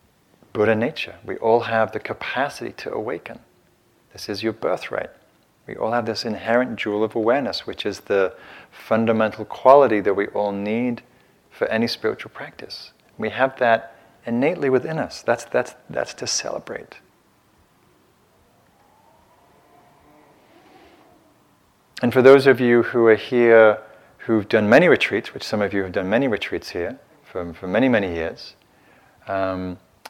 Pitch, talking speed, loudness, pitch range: 110 Hz, 145 wpm, -20 LUFS, 105-120 Hz